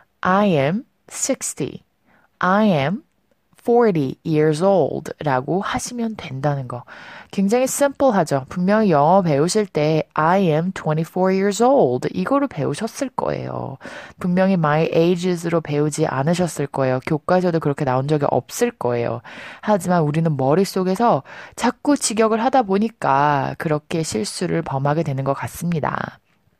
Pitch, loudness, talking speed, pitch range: 175 Hz, -19 LUFS, 310 characters per minute, 145-210 Hz